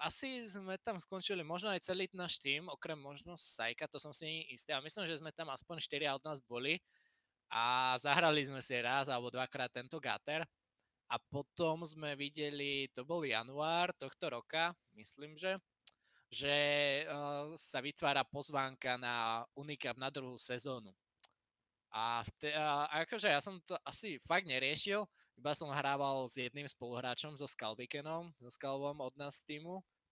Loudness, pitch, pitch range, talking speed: -38 LUFS, 145 Hz, 130-160 Hz, 155 wpm